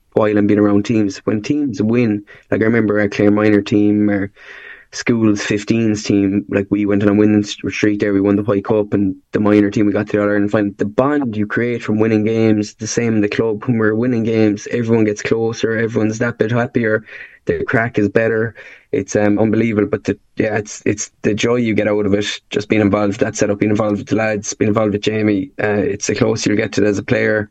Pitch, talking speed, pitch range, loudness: 105 Hz, 240 wpm, 105-110 Hz, -16 LUFS